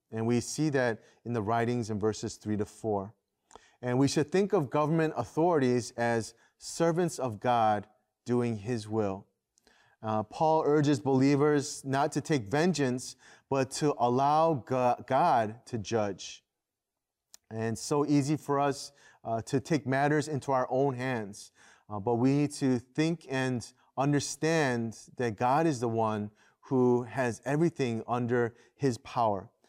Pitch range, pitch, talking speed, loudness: 115-145 Hz, 125 Hz, 150 wpm, -30 LUFS